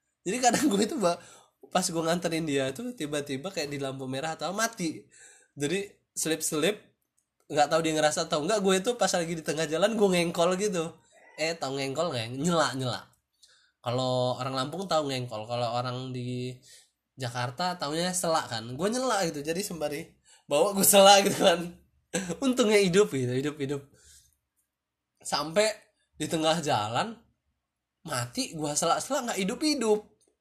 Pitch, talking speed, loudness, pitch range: 160 Hz, 155 wpm, -27 LUFS, 130-190 Hz